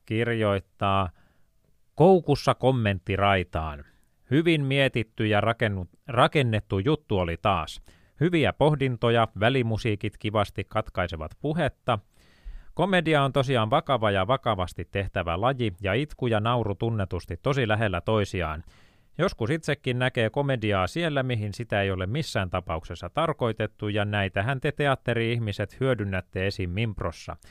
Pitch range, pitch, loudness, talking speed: 95-130 Hz, 110 Hz, -26 LUFS, 120 wpm